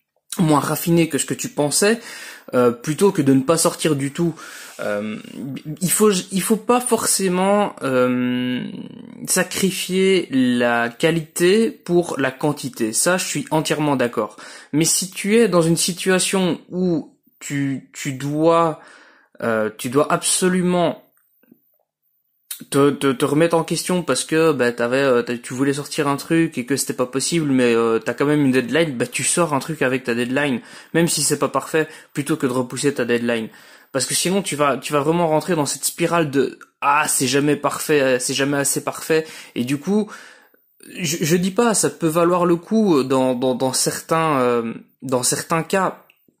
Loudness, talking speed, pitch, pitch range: -19 LUFS, 175 wpm, 155 Hz, 135-180 Hz